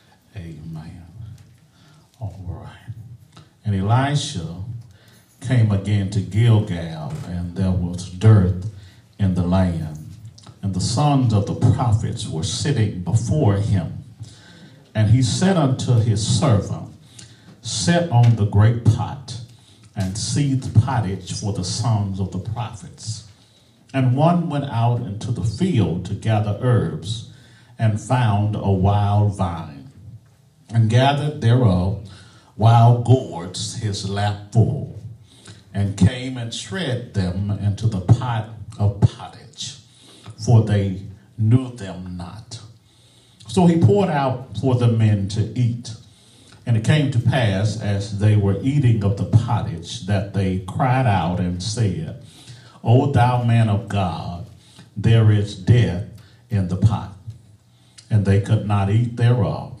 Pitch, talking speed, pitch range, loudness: 110 Hz, 130 wpm, 100-120 Hz, -20 LUFS